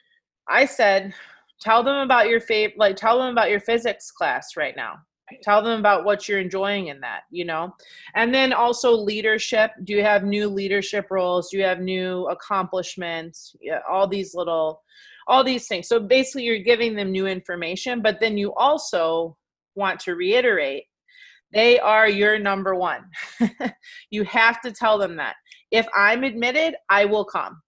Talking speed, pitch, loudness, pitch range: 170 wpm, 215 Hz, -21 LUFS, 195-240 Hz